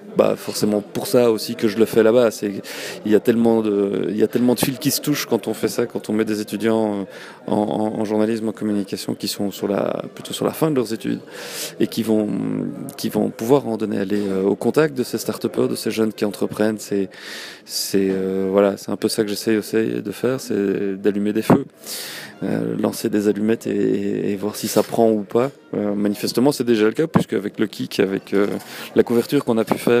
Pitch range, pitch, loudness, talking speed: 105-115 Hz, 110 Hz, -20 LUFS, 230 wpm